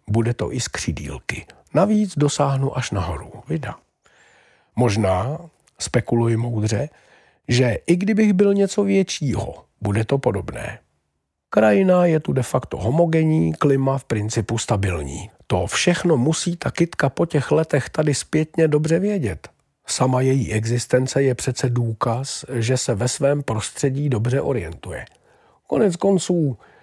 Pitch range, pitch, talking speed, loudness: 115-160 Hz, 130 Hz, 130 wpm, -20 LUFS